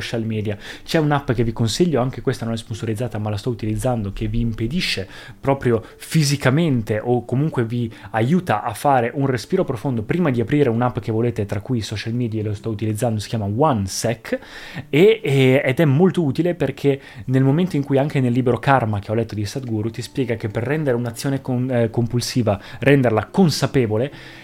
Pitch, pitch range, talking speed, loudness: 120 Hz, 115-140 Hz, 185 wpm, -20 LUFS